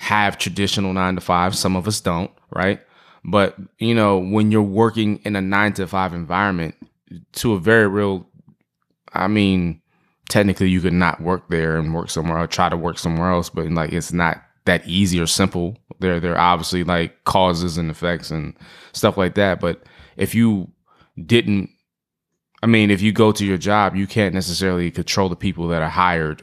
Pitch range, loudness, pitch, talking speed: 85-100 Hz, -19 LUFS, 95 Hz, 185 wpm